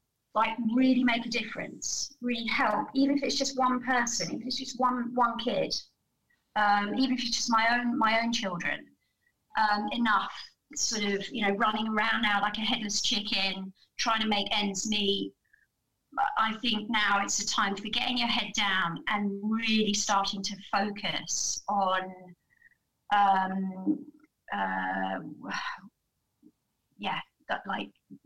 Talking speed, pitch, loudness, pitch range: 145 wpm, 220 Hz, -29 LUFS, 200-240 Hz